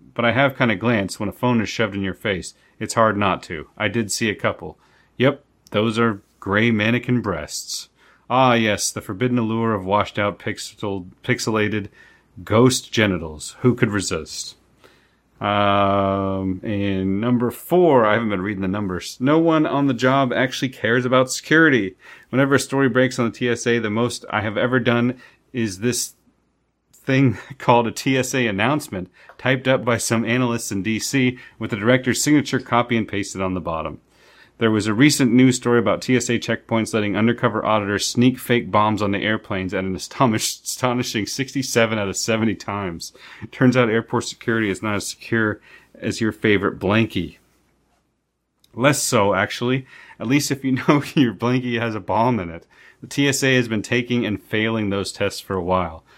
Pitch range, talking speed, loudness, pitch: 100-125 Hz, 175 wpm, -20 LUFS, 115 Hz